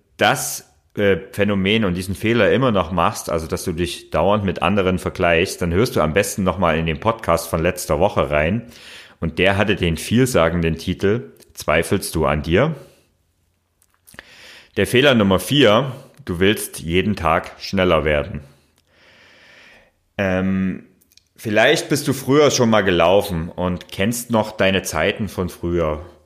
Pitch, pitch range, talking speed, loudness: 95 Hz, 85-105 Hz, 150 wpm, -18 LUFS